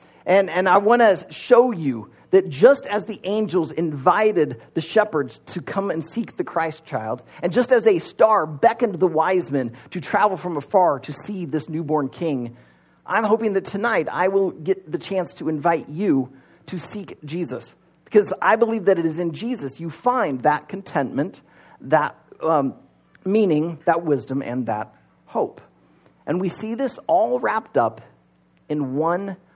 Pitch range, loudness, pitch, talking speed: 150-205 Hz, -21 LUFS, 175 Hz, 175 wpm